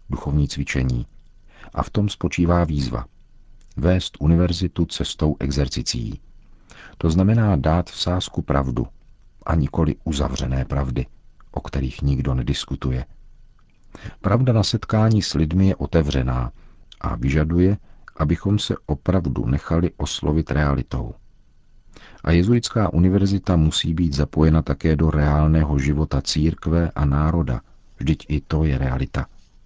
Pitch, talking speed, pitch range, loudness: 80 Hz, 115 wpm, 70-90 Hz, -21 LUFS